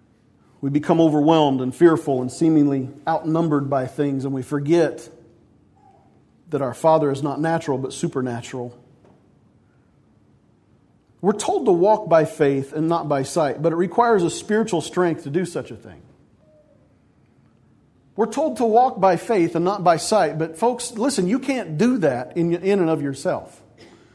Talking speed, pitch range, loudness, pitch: 155 wpm, 135-180 Hz, -20 LUFS, 160 Hz